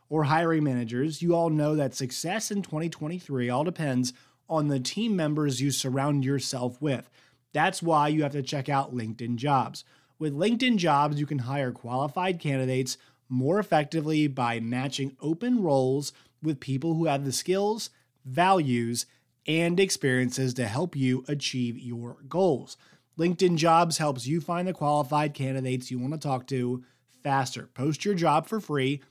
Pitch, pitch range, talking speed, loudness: 140 Hz, 130-160 Hz, 160 wpm, -27 LUFS